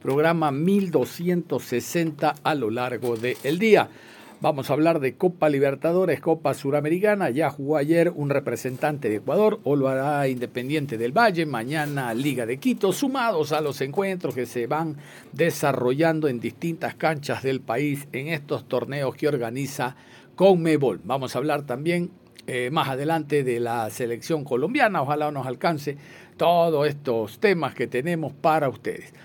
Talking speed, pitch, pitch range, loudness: 150 wpm, 145 Hz, 130-165 Hz, -24 LUFS